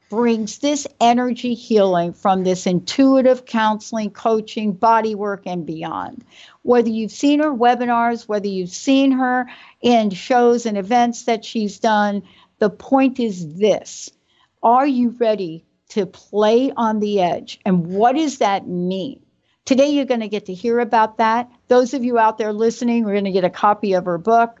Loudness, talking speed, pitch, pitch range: -18 LUFS, 170 wpm, 225 Hz, 205-245 Hz